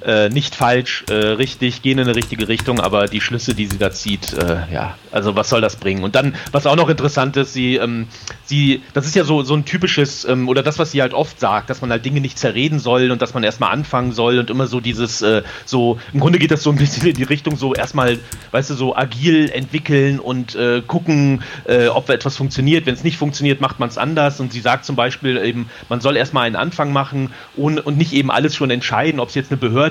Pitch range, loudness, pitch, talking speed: 120-145 Hz, -17 LUFS, 130 Hz, 250 wpm